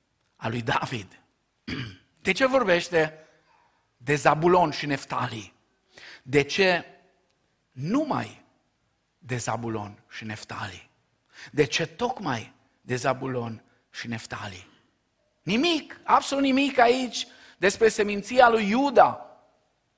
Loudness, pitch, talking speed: -25 LUFS, 155 Hz, 95 wpm